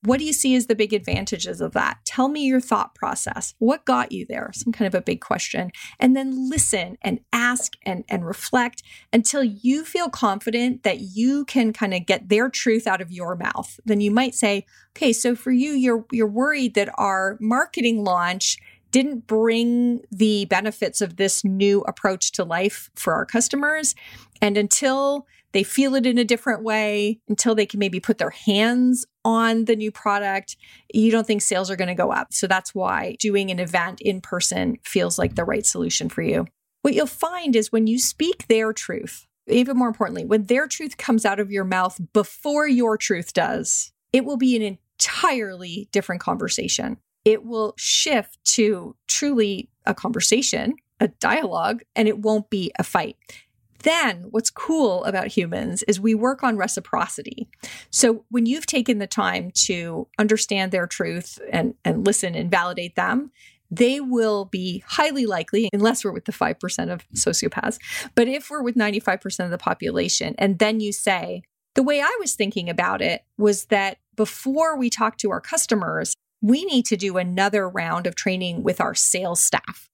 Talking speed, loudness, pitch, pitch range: 180 wpm, -21 LUFS, 220 Hz, 200-250 Hz